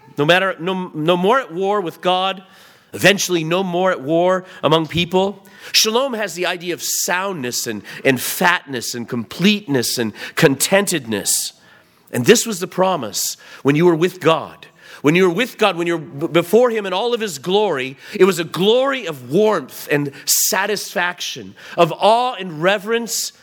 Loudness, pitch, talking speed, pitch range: -17 LUFS, 180 Hz, 170 wpm, 160-200 Hz